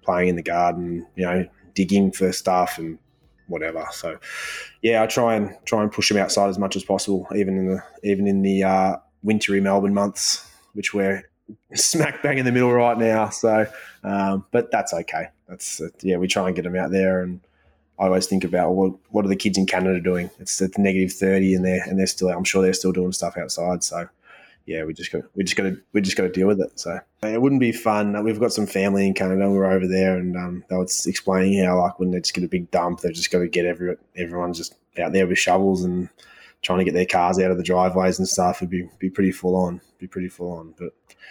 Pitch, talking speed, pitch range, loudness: 95 Hz, 250 wpm, 90-100 Hz, -22 LUFS